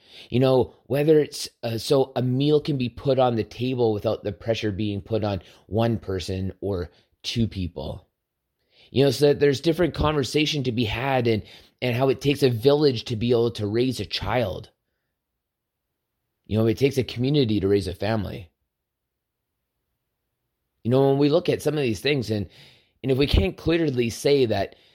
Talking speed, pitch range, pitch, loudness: 185 wpm, 100-135 Hz, 120 Hz, -23 LUFS